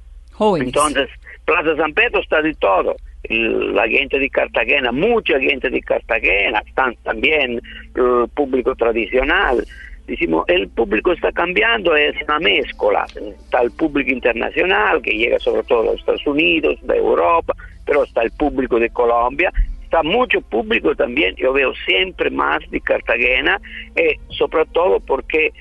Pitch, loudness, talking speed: 330 Hz, -17 LUFS, 140 wpm